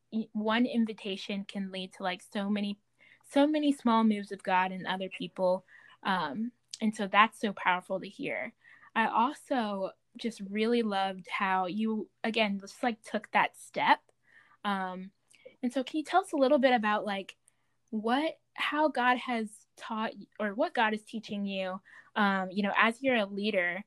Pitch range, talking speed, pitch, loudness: 195-240 Hz, 170 wpm, 215 Hz, -31 LUFS